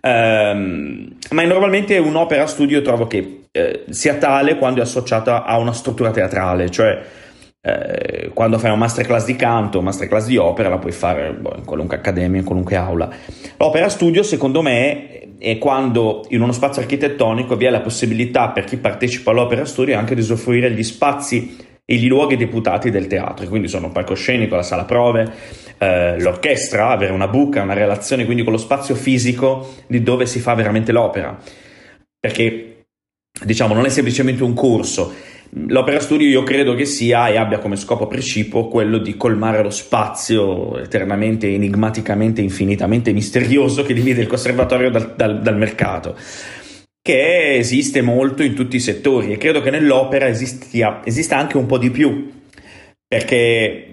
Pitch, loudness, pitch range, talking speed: 120 Hz, -16 LUFS, 110-135 Hz, 165 wpm